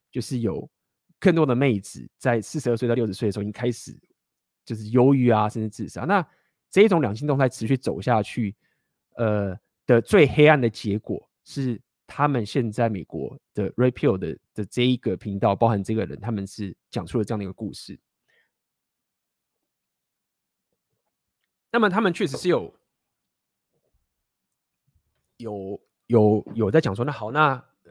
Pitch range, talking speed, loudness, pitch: 105-130 Hz, 240 characters per minute, -23 LUFS, 115 Hz